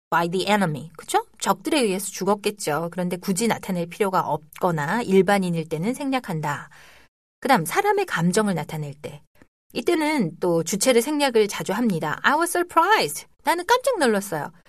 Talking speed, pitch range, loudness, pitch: 390 characters per minute, 170-275 Hz, -22 LUFS, 200 Hz